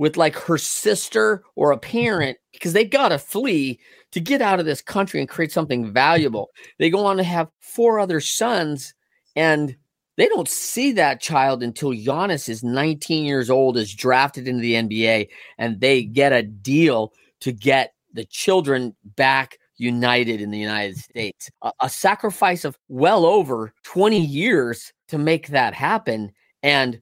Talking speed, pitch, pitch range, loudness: 165 wpm, 140 Hz, 120-170 Hz, -20 LUFS